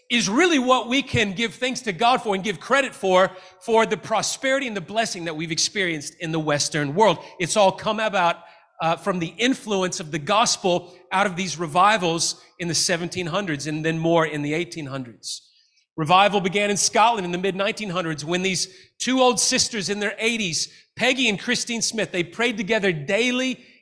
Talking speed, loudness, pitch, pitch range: 190 wpm, -22 LUFS, 195 Hz, 170-225 Hz